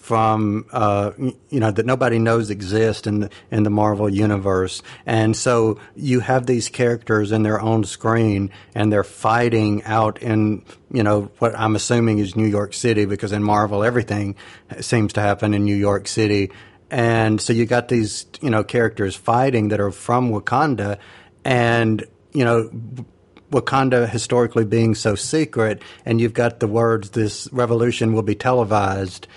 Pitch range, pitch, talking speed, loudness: 105-120 Hz, 110 Hz, 165 wpm, -19 LUFS